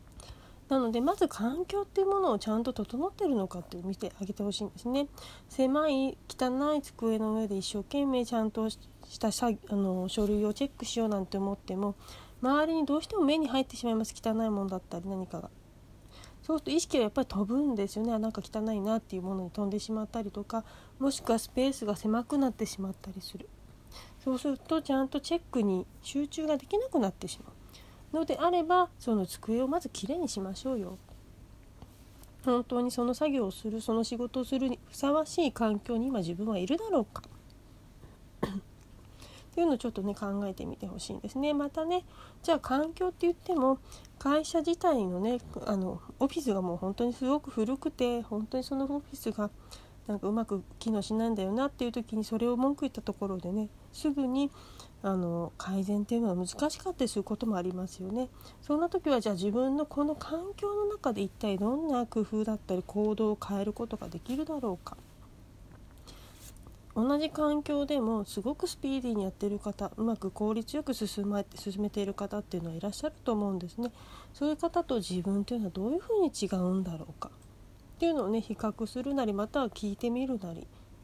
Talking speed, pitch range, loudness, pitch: 400 characters per minute, 200-275 Hz, -32 LUFS, 225 Hz